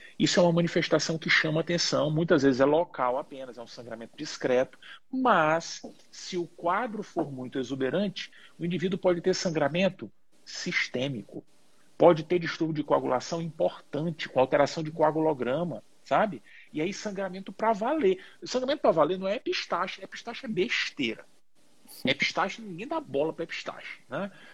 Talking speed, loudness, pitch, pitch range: 150 wpm, -28 LUFS, 170 Hz, 150-195 Hz